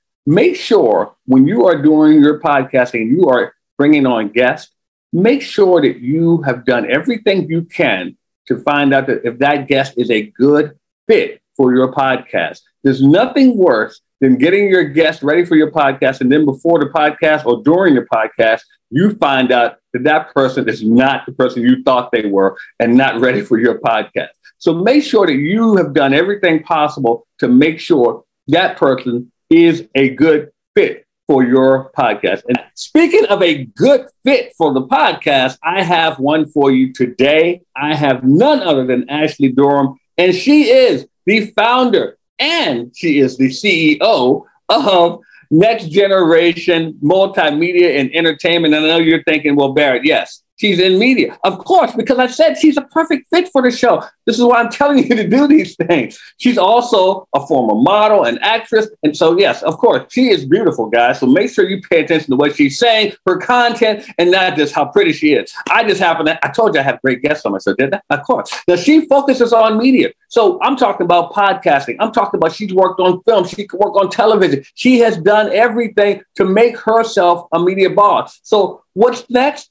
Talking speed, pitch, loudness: 195 wpm, 175 Hz, -13 LUFS